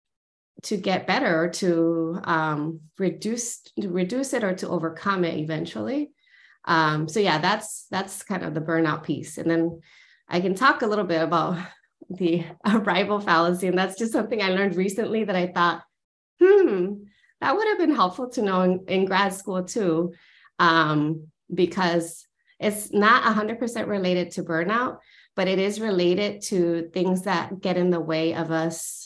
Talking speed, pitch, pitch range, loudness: 165 wpm, 185 Hz, 165-210 Hz, -24 LUFS